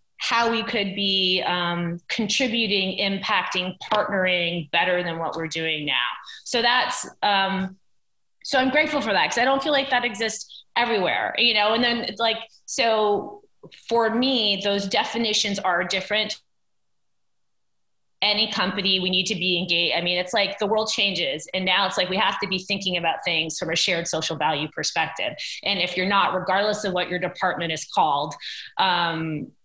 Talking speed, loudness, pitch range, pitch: 175 wpm, -22 LUFS, 180-225 Hz, 195 Hz